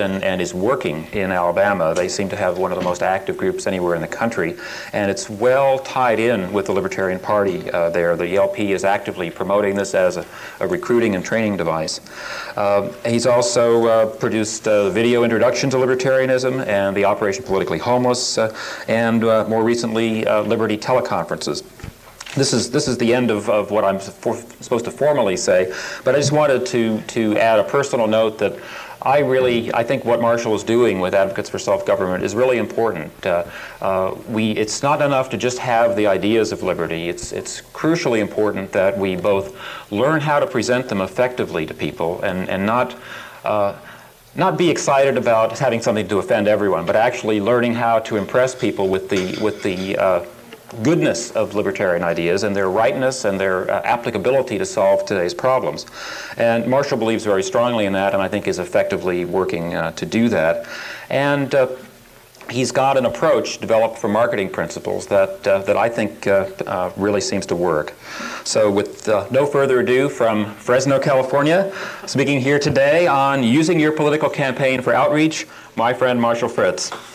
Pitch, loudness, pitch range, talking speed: 115 Hz, -18 LUFS, 100-130 Hz, 185 wpm